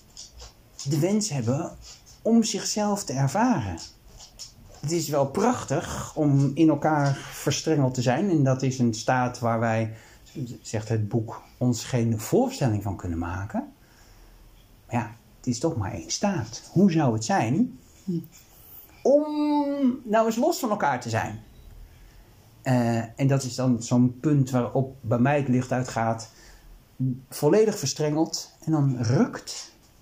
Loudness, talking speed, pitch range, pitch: -25 LUFS, 140 wpm, 115-155 Hz, 125 Hz